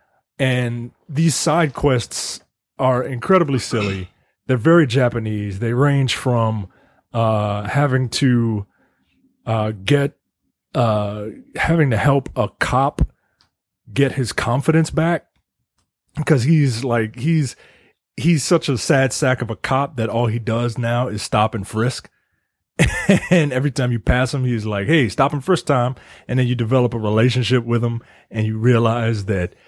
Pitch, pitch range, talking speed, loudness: 125 Hz, 110-140 Hz, 150 wpm, -19 LUFS